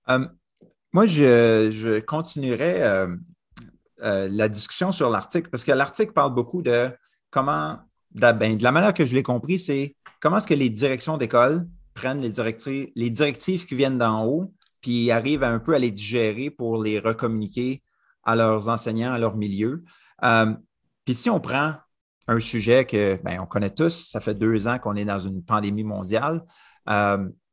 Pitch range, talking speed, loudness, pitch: 110-150 Hz, 180 wpm, -23 LUFS, 120 Hz